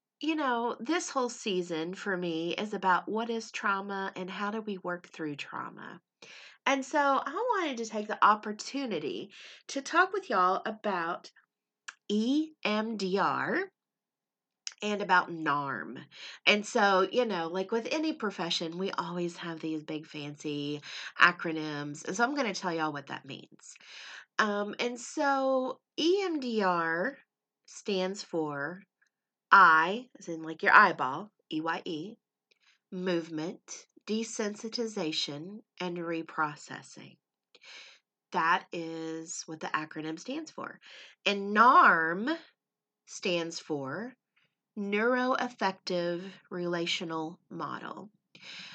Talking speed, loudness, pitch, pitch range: 110 wpm, -30 LUFS, 195 Hz, 170-240 Hz